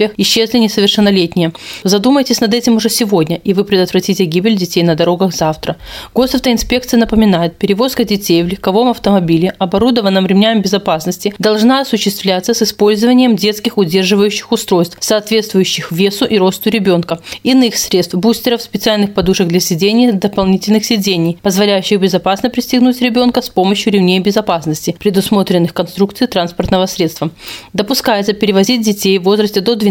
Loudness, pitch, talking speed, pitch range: -12 LUFS, 205 Hz, 130 wpm, 185-225 Hz